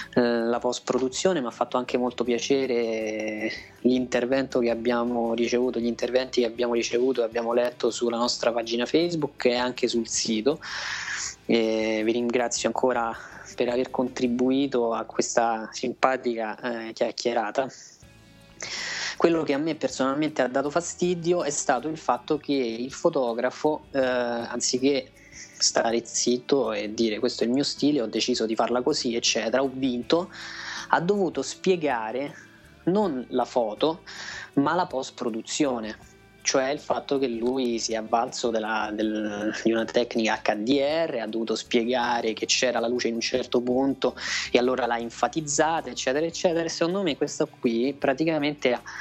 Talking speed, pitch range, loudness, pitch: 145 wpm, 115-135 Hz, -26 LUFS, 125 Hz